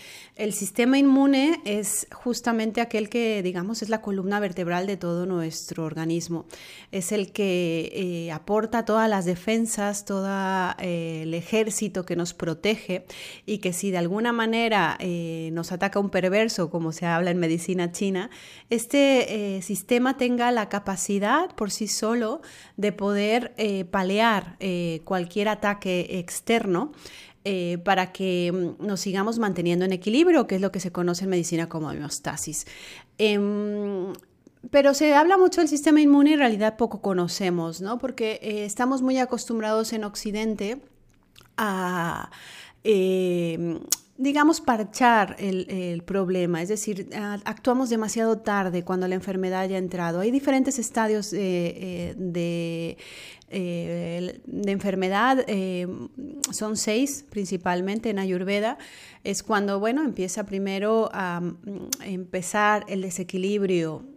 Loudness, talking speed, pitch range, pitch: -25 LUFS, 135 wpm, 180-220 Hz, 200 Hz